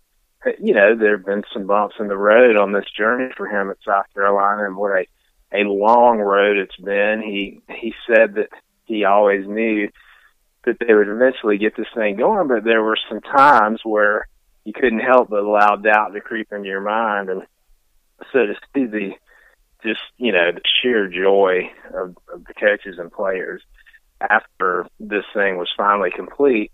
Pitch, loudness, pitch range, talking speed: 105 Hz, -17 LUFS, 100-110 Hz, 180 wpm